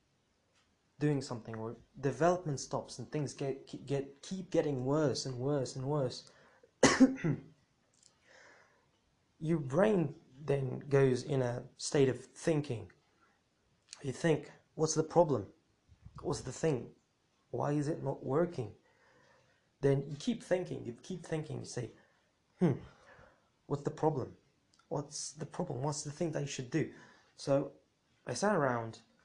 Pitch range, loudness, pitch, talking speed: 130-155 Hz, -35 LUFS, 140 Hz, 130 wpm